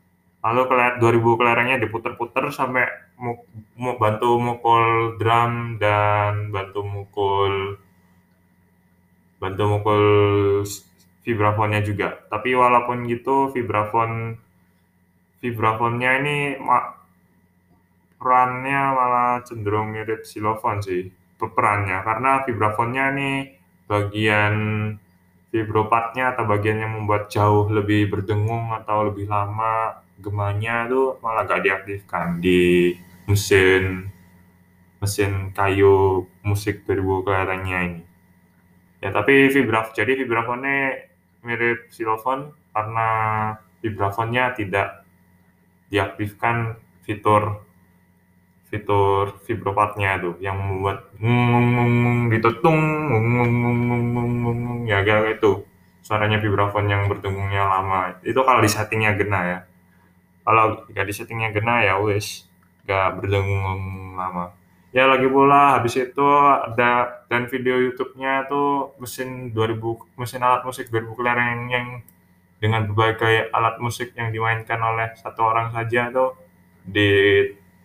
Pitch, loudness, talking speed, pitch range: 105 Hz, -20 LUFS, 105 wpm, 95-120 Hz